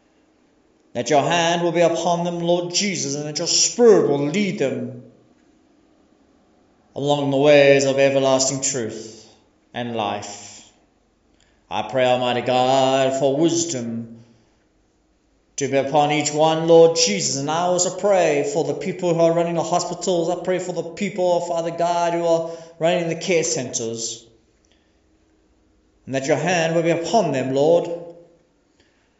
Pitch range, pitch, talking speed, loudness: 125-170 Hz, 150 Hz, 150 wpm, -19 LUFS